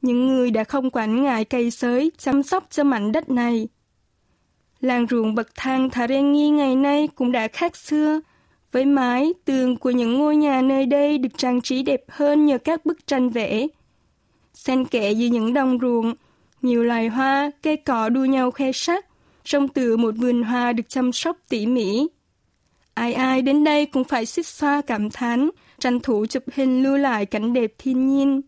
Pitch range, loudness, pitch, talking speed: 240-285 Hz, -21 LUFS, 260 Hz, 190 wpm